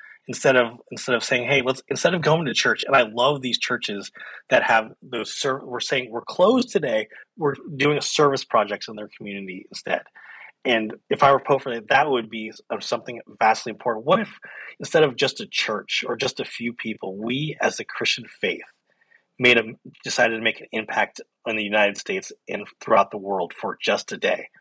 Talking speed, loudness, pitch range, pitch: 205 wpm, -22 LUFS, 110-140 Hz, 125 Hz